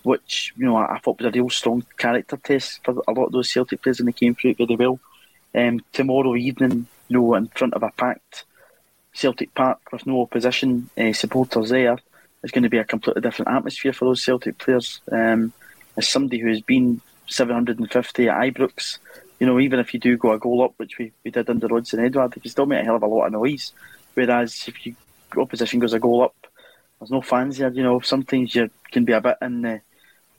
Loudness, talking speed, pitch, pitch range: -21 LUFS, 225 wpm, 120 Hz, 115-130 Hz